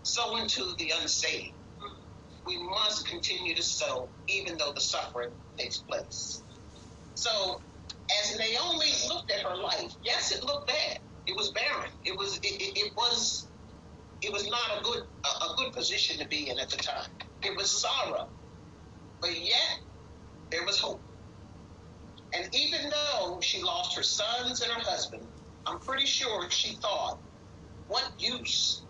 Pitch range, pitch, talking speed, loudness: 235-325 Hz, 270 Hz, 155 wpm, -30 LUFS